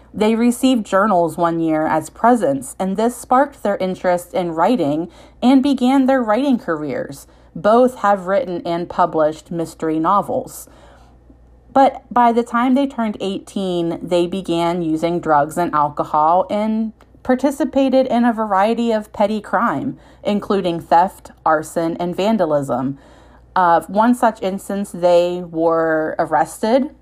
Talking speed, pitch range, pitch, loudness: 130 wpm, 170-235 Hz, 190 Hz, -17 LUFS